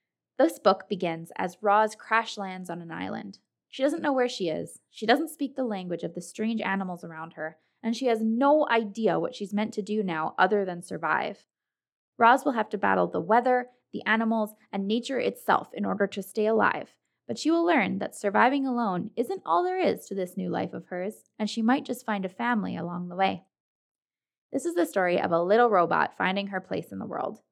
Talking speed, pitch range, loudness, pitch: 215 wpm, 190-245 Hz, -27 LUFS, 215 Hz